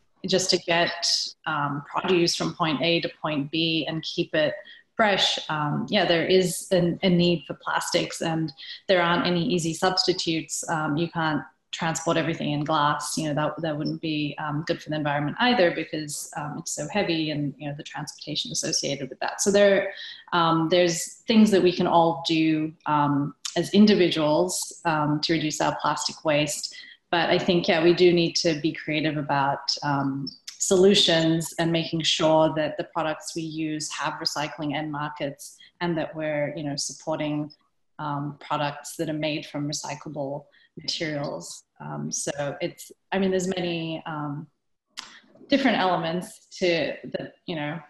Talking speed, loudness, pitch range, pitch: 170 wpm, -24 LUFS, 150-175 Hz, 165 Hz